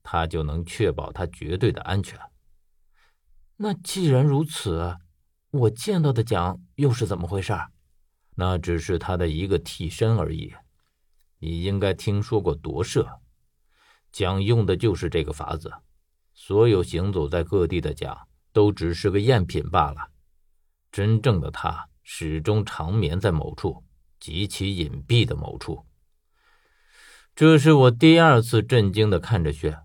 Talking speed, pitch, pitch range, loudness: 205 characters per minute, 95 Hz, 80-115 Hz, -23 LUFS